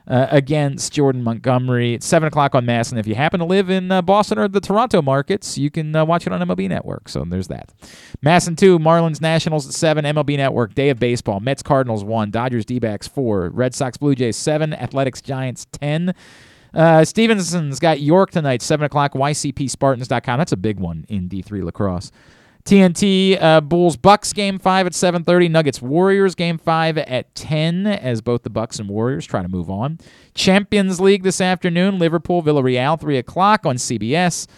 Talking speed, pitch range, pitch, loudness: 190 wpm, 125-175 Hz, 145 Hz, -17 LUFS